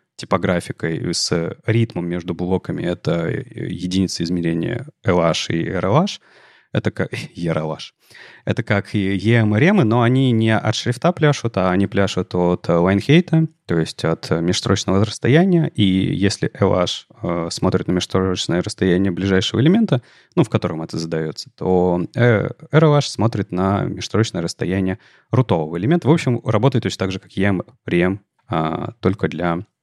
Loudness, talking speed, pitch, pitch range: -19 LUFS, 140 wpm, 100 Hz, 90-120 Hz